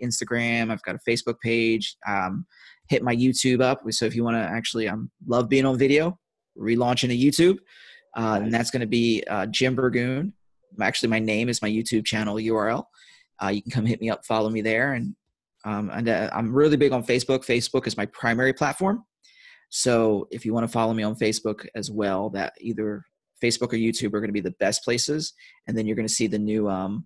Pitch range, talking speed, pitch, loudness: 110-125 Hz, 215 wpm, 115 Hz, -24 LUFS